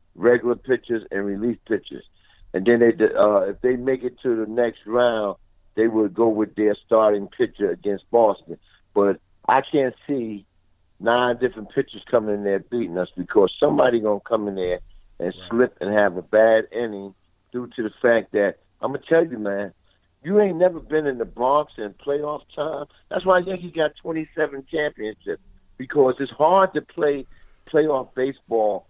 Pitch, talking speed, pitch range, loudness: 115 Hz, 170 wpm, 100-135 Hz, -22 LUFS